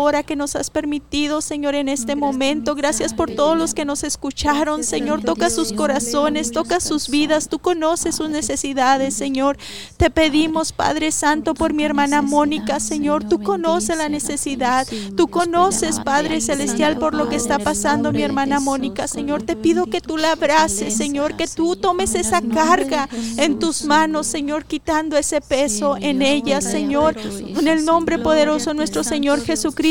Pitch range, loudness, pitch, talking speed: 285-320 Hz, -19 LUFS, 300 Hz, 165 wpm